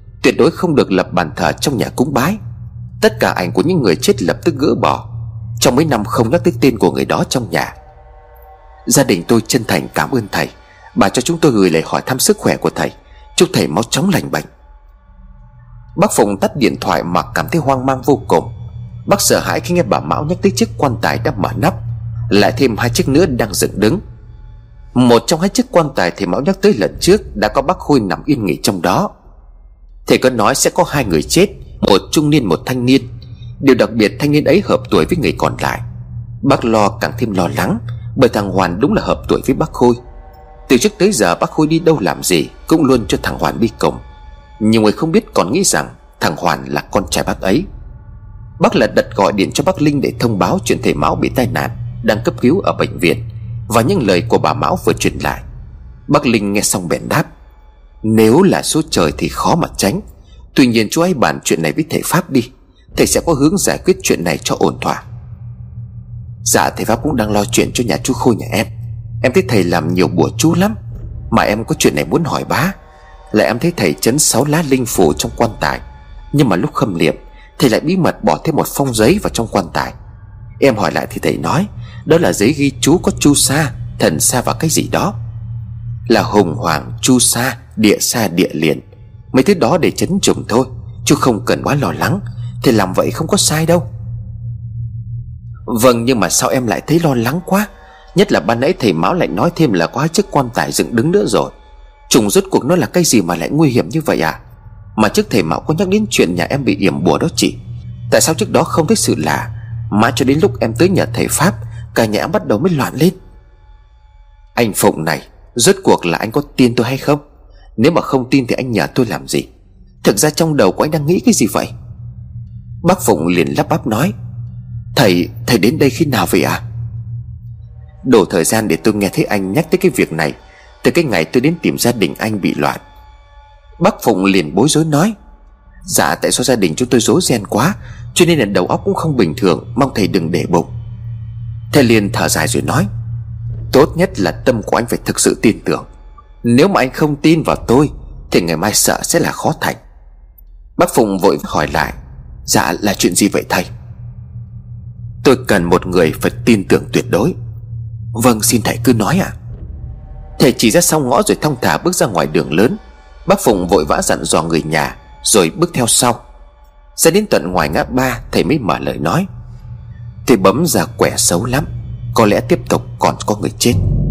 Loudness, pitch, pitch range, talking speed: -14 LUFS, 115 Hz, 110-140 Hz, 225 wpm